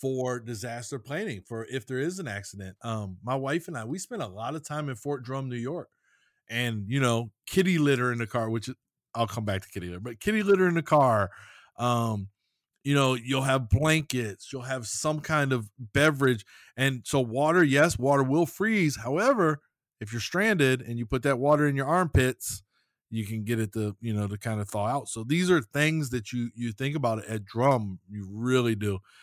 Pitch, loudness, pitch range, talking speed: 130 Hz, -27 LUFS, 115-145 Hz, 215 wpm